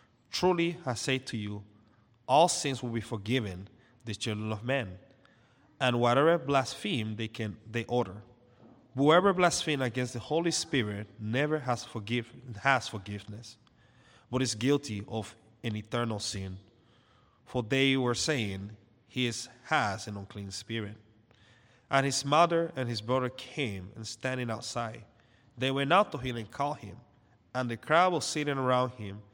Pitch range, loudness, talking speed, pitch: 110-135 Hz, -30 LUFS, 150 wpm, 120 Hz